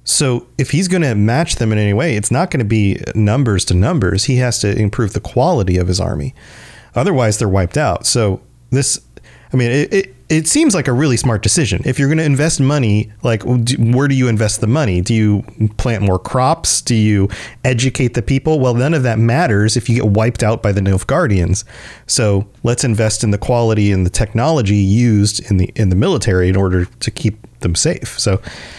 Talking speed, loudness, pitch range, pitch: 215 wpm, -15 LUFS, 105-130 Hz, 115 Hz